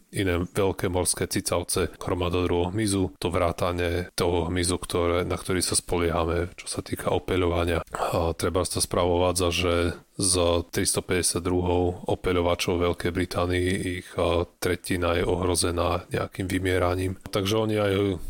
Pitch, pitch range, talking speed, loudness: 90 Hz, 85-95 Hz, 120 wpm, -25 LUFS